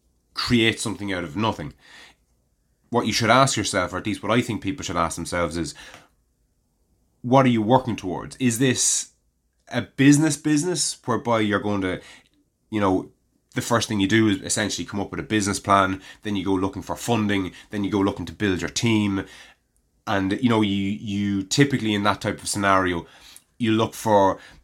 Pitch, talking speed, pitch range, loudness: 105 Hz, 190 wpm, 95-115 Hz, -22 LUFS